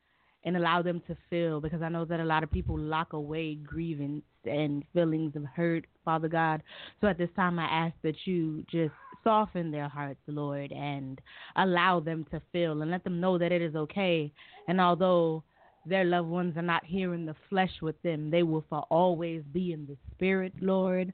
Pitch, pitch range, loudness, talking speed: 165 Hz, 155-175 Hz, -31 LUFS, 200 wpm